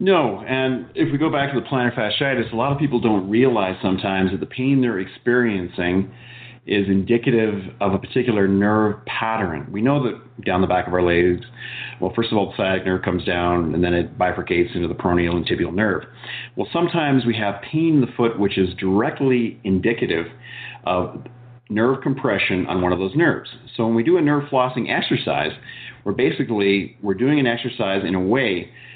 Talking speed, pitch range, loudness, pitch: 195 wpm, 95-125 Hz, -20 LUFS, 110 Hz